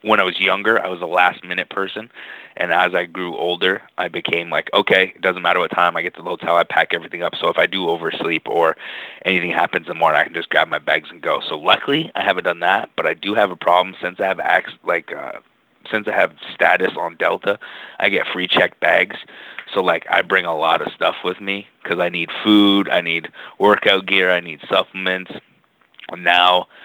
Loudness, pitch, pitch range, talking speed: -18 LUFS, 90 Hz, 90-100 Hz, 230 wpm